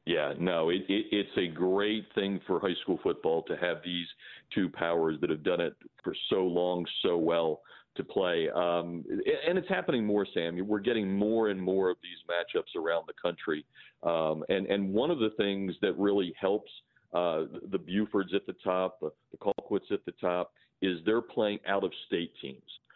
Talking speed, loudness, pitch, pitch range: 190 wpm, -31 LUFS, 95 Hz, 90-105 Hz